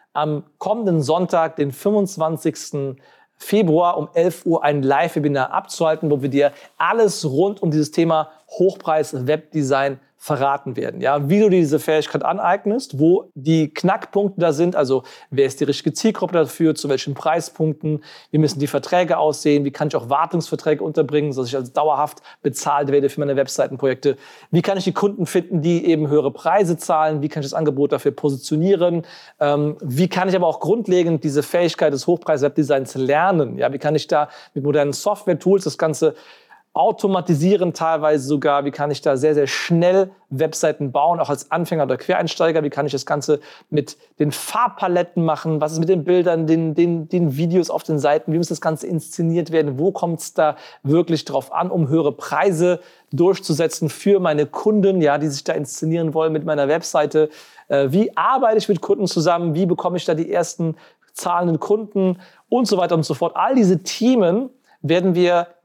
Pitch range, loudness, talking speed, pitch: 150-180 Hz, -19 LUFS, 180 wpm, 160 Hz